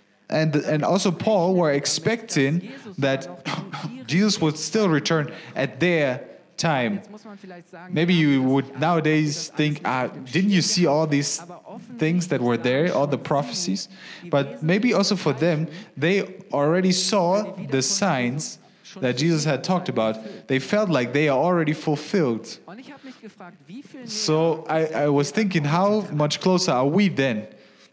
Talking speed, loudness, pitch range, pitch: 140 wpm, -22 LUFS, 145-190 Hz, 165 Hz